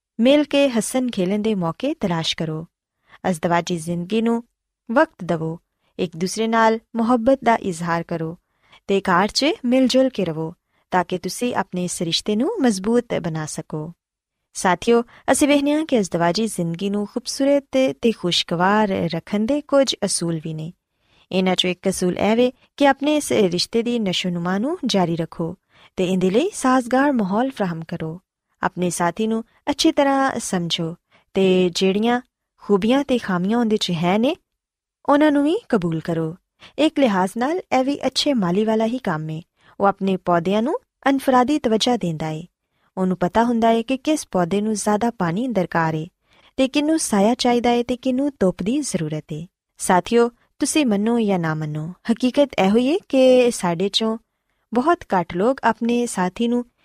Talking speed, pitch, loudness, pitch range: 160 wpm, 215 Hz, -20 LUFS, 180-255 Hz